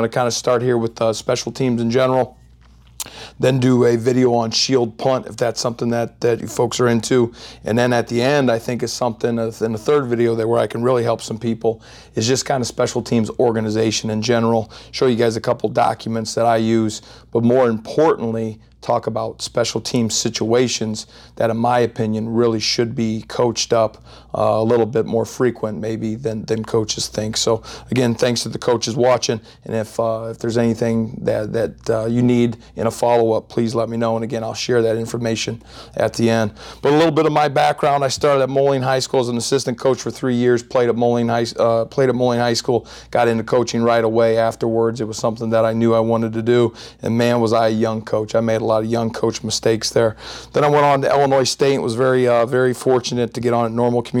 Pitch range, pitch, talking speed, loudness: 115-120 Hz, 115 Hz, 230 wpm, -18 LUFS